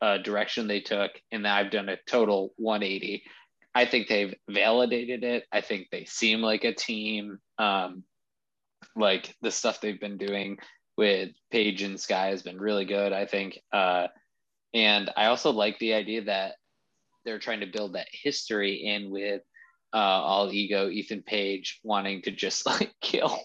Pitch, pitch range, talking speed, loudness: 100 Hz, 100-110 Hz, 165 wpm, -28 LUFS